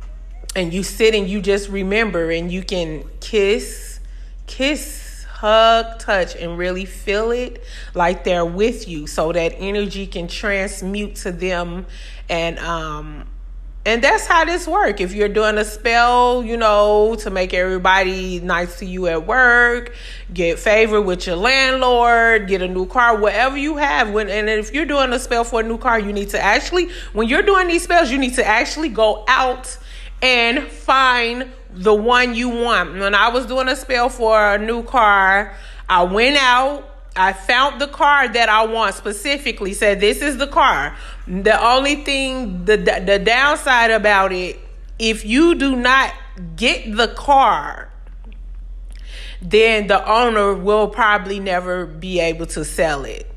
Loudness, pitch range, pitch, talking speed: -16 LUFS, 190-250 Hz, 220 Hz, 165 wpm